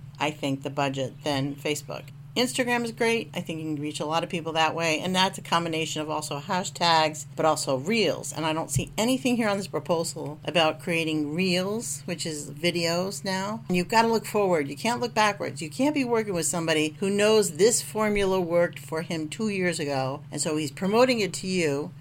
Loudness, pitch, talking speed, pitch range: -26 LUFS, 165 Hz, 215 wpm, 150-200 Hz